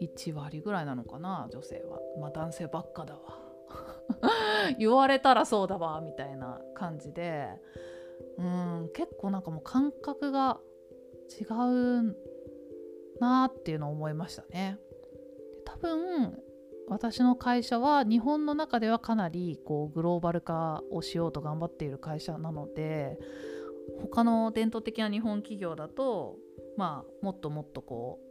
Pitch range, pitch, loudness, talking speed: 150-235 Hz, 175 Hz, -31 LUFS, 270 characters per minute